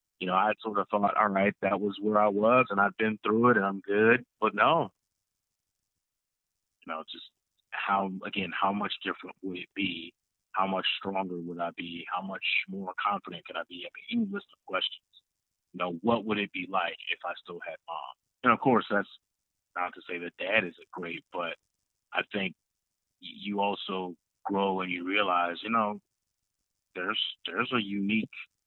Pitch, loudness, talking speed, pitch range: 100 Hz, -29 LUFS, 190 wpm, 95-105 Hz